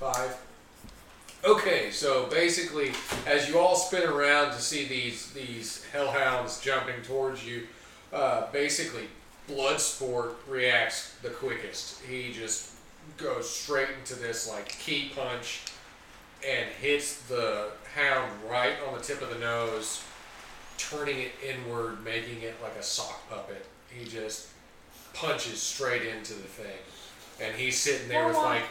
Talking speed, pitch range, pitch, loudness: 135 wpm, 115-140 Hz, 125 Hz, -29 LUFS